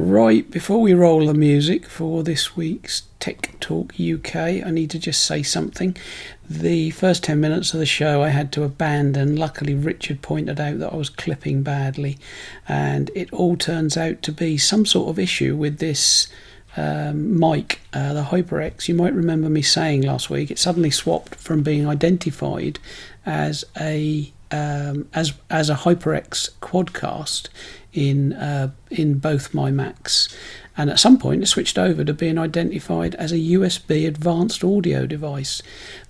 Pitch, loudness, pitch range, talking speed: 150 Hz, -20 LUFS, 140-165 Hz, 165 wpm